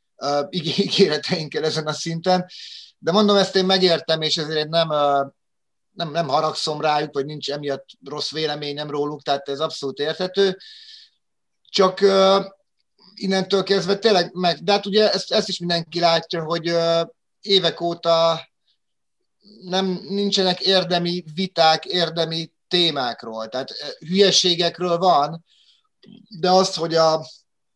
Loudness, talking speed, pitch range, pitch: -20 LUFS, 120 wpm, 160-195 Hz, 170 Hz